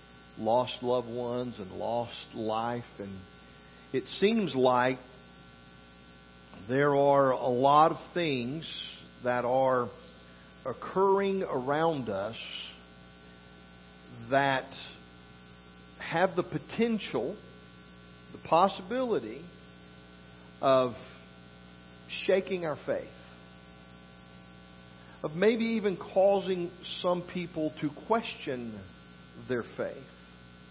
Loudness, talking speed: -30 LUFS, 80 wpm